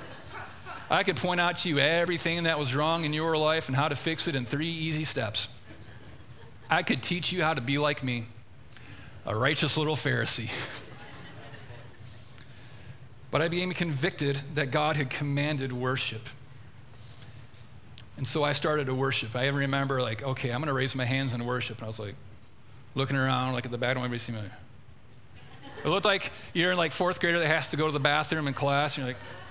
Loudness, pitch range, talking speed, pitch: -27 LUFS, 120-155 Hz, 195 wpm, 130 Hz